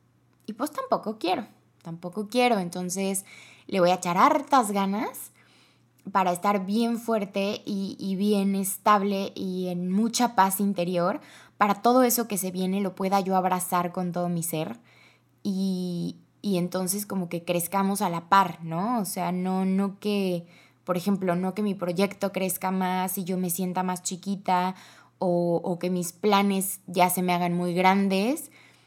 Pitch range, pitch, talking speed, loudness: 180-200 Hz, 190 Hz, 165 wpm, -26 LUFS